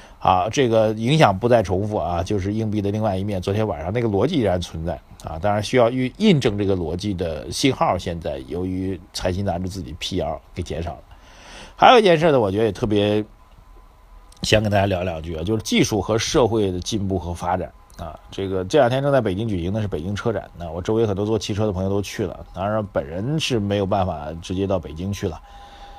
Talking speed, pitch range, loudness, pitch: 335 characters per minute, 90-110 Hz, -21 LUFS, 100 Hz